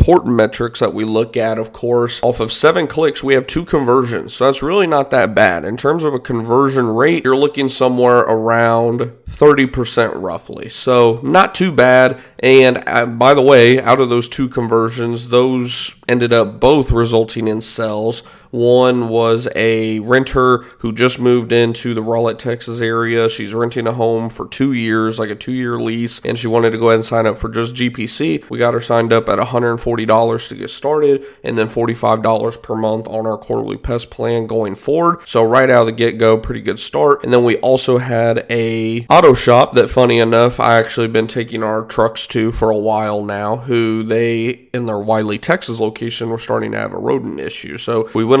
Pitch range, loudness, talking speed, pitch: 115-125 Hz, -14 LUFS, 195 wpm, 115 Hz